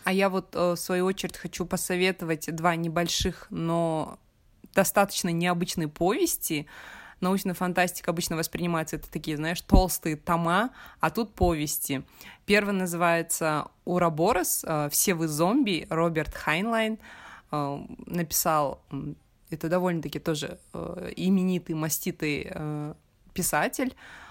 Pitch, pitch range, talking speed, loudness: 175 Hz, 160-185 Hz, 100 wpm, -27 LUFS